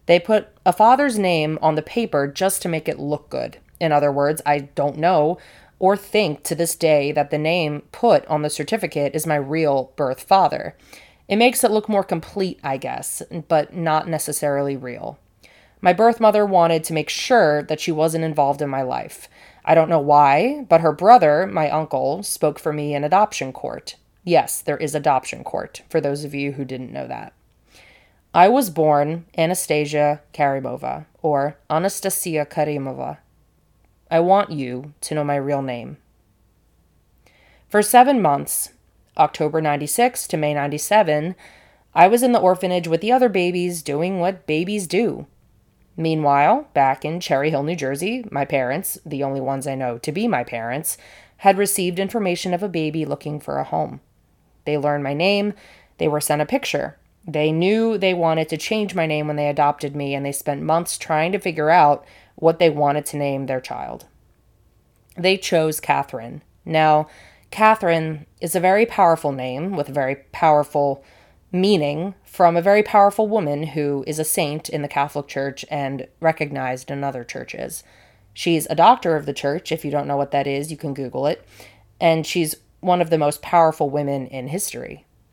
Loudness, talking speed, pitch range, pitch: -20 LUFS, 175 wpm, 145-180 Hz, 155 Hz